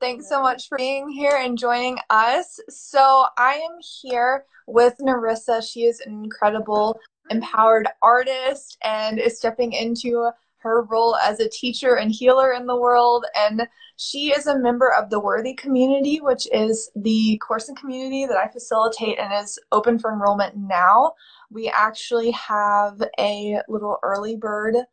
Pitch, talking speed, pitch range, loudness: 235 Hz, 160 wpm, 220-260 Hz, -20 LUFS